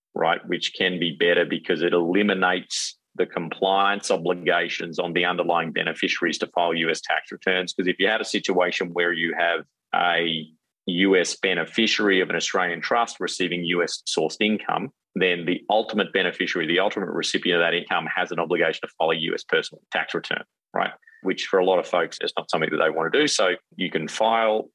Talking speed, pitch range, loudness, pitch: 190 wpm, 85-100 Hz, -23 LUFS, 90 Hz